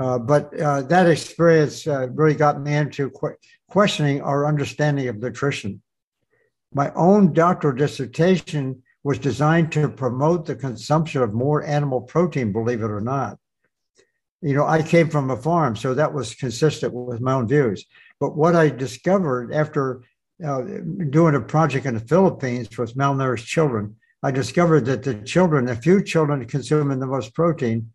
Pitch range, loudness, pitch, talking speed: 130-160 Hz, -21 LUFS, 145 Hz, 165 wpm